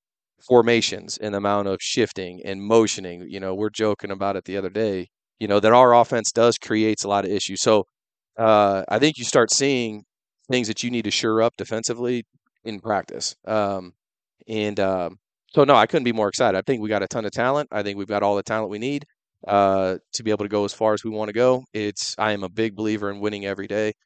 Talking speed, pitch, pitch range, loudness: 235 wpm, 105 Hz, 100-115 Hz, -22 LUFS